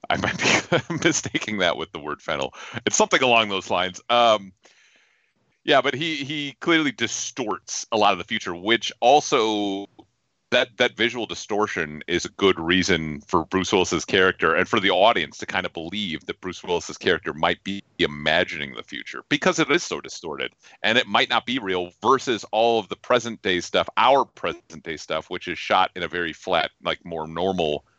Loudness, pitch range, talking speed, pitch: -22 LUFS, 90-120 Hz, 190 wpm, 105 Hz